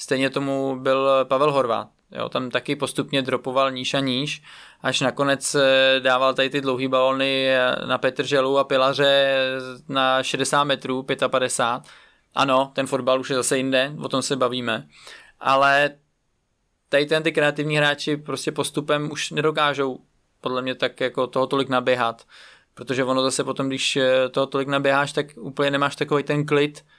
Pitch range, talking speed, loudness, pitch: 130-140 Hz, 155 wpm, -21 LUFS, 135 Hz